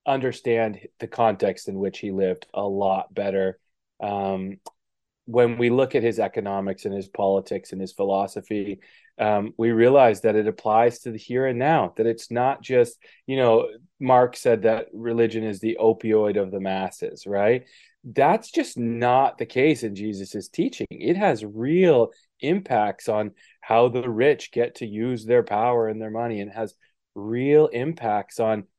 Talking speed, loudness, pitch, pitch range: 165 wpm, -23 LUFS, 115 Hz, 100-125 Hz